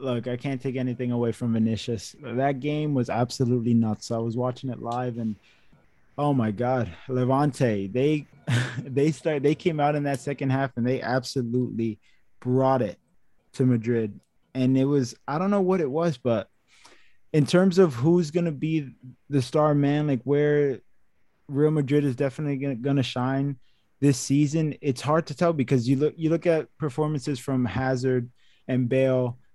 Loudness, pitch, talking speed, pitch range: -25 LUFS, 135 Hz, 170 wpm, 125-145 Hz